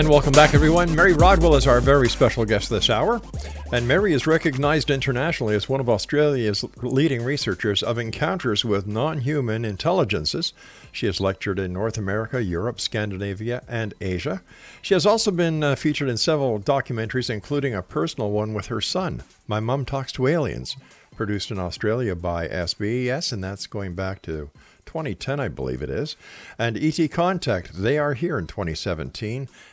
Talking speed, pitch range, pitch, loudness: 170 wpm, 100-145 Hz, 120 Hz, -22 LUFS